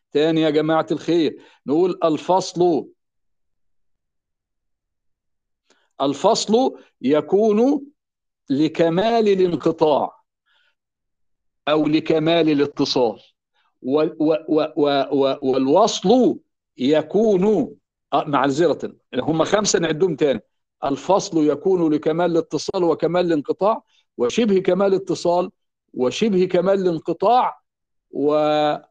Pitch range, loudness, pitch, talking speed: 145-190 Hz, -19 LUFS, 160 Hz, 70 wpm